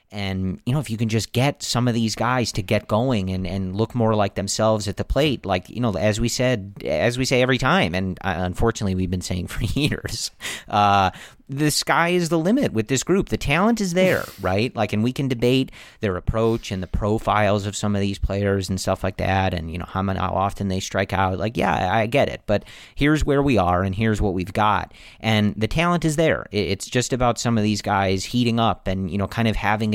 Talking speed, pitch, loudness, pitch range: 240 wpm, 105 Hz, -22 LUFS, 95-125 Hz